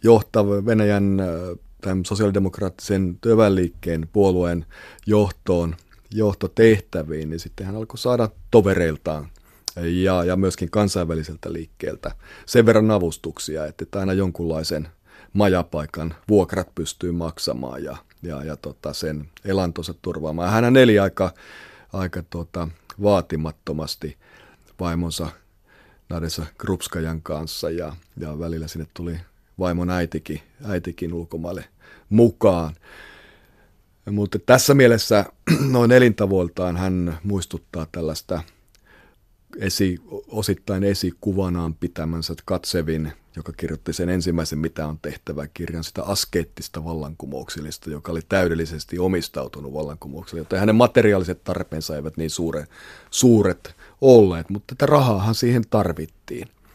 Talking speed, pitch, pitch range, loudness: 105 wpm, 90 Hz, 80-100 Hz, -21 LUFS